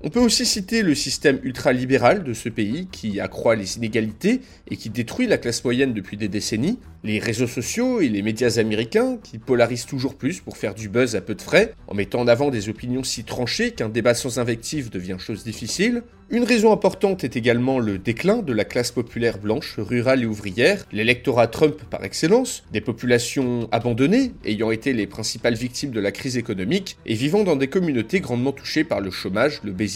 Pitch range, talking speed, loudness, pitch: 110-140 Hz, 200 wpm, -22 LUFS, 120 Hz